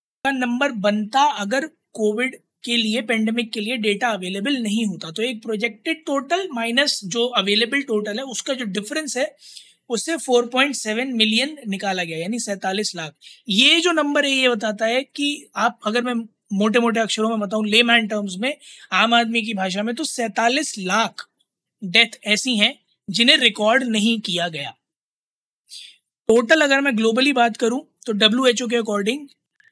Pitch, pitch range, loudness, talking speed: 235 Hz, 215-265 Hz, -19 LUFS, 160 wpm